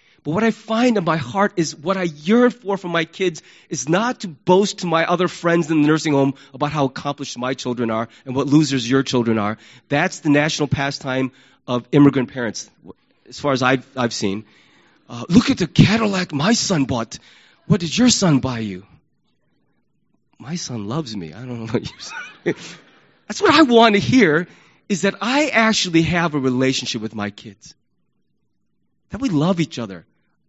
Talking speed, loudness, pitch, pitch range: 190 wpm, -19 LUFS, 150 Hz, 125-185 Hz